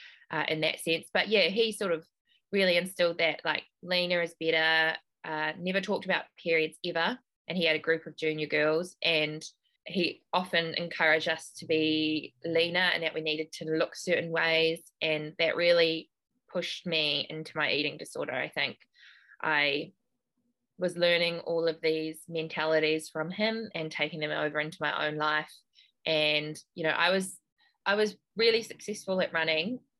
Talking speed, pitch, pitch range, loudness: 170 wpm, 165 Hz, 155-180 Hz, -29 LUFS